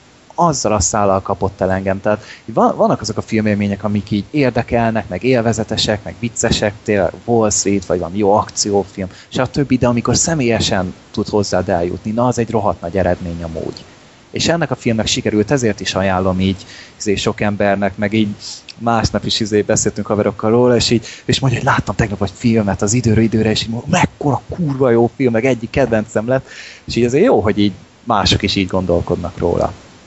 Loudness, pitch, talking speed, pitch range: -16 LUFS, 105 Hz, 190 wpm, 100-115 Hz